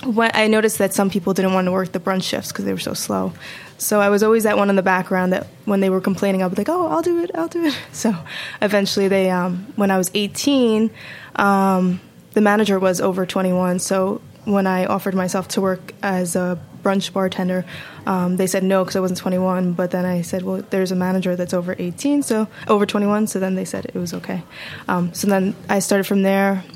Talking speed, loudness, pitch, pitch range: 230 wpm, -19 LUFS, 195 Hz, 185-205 Hz